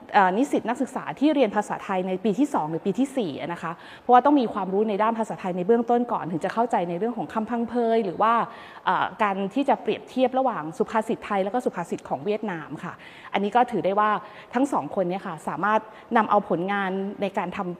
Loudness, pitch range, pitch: -25 LUFS, 190-240 Hz, 215 Hz